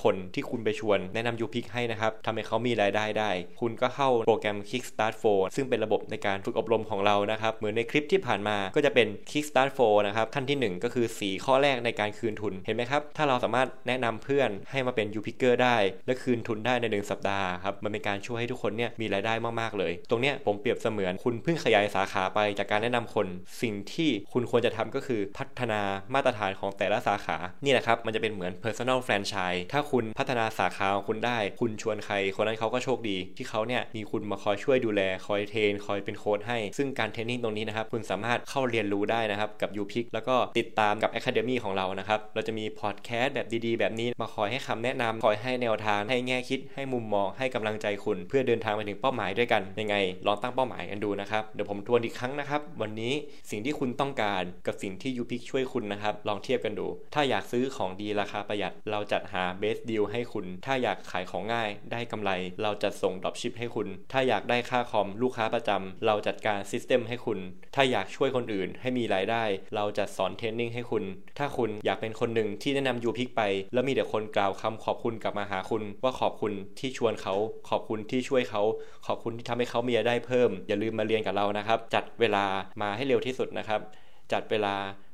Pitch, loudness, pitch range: 110 Hz, -29 LUFS, 100-120 Hz